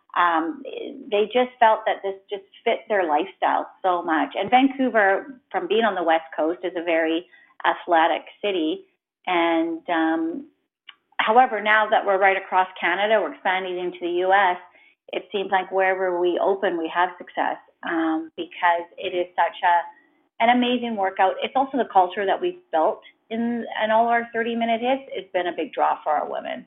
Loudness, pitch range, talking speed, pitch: -22 LUFS, 175-235 Hz, 180 wpm, 195 Hz